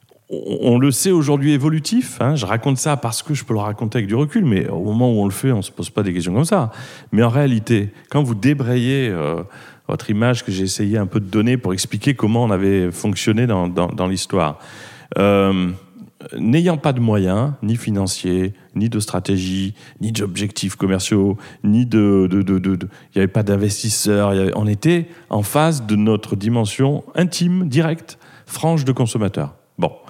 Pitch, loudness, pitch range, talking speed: 110 Hz, -18 LUFS, 100-135 Hz, 195 wpm